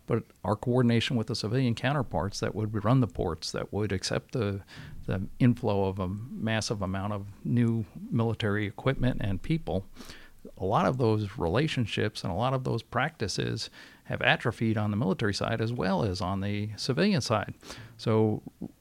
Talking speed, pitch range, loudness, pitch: 170 wpm, 100-125 Hz, -29 LUFS, 110 Hz